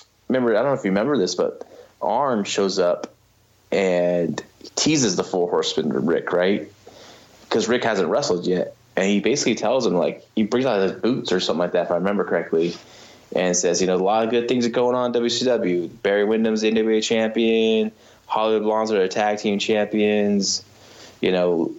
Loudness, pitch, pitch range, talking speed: -21 LUFS, 110 Hz, 95-115 Hz, 195 wpm